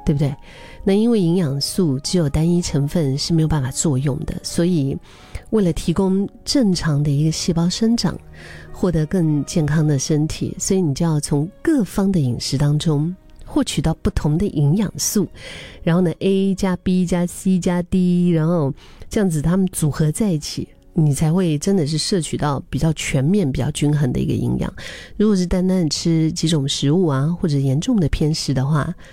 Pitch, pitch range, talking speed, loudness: 165 Hz, 150-185 Hz, 270 characters per minute, -19 LUFS